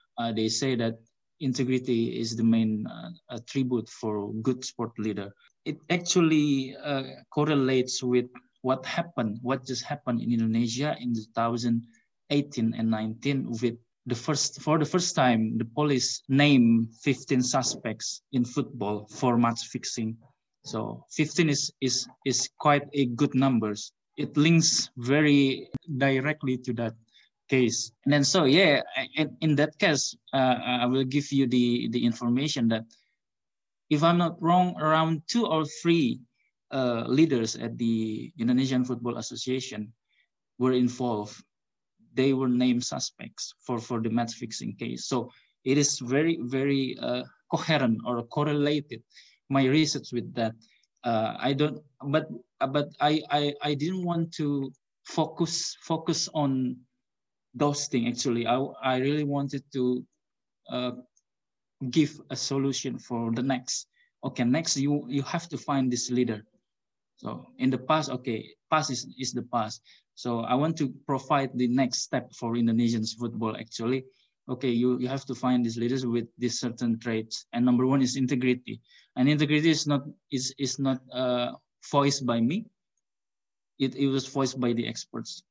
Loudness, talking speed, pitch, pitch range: -27 LUFS, 150 wpm, 130 Hz, 120-145 Hz